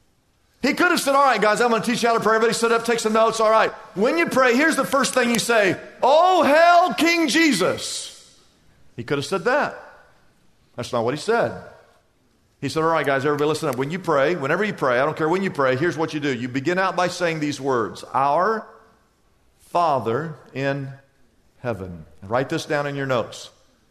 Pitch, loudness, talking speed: 190 Hz, -20 LUFS, 220 wpm